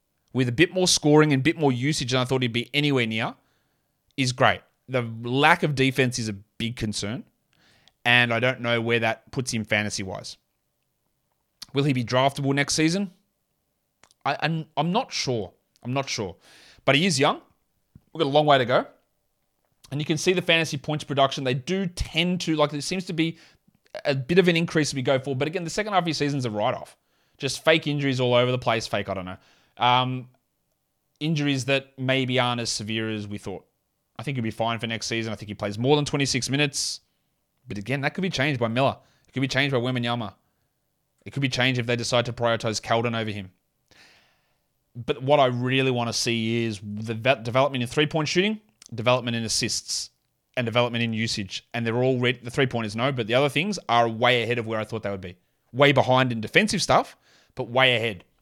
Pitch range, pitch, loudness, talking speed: 115-145 Hz, 130 Hz, -24 LUFS, 225 wpm